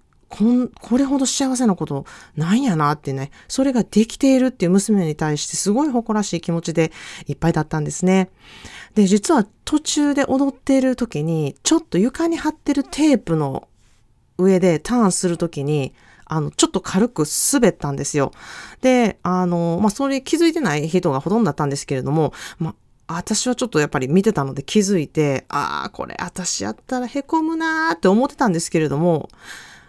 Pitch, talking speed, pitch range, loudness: 185 Hz, 370 characters per minute, 155-255 Hz, -19 LUFS